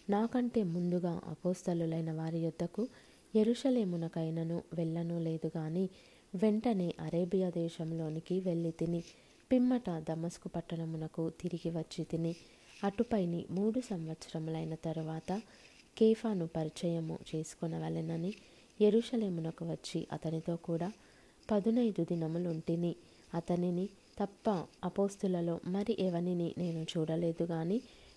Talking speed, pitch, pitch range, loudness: 85 wpm, 170 Hz, 165-195 Hz, -36 LUFS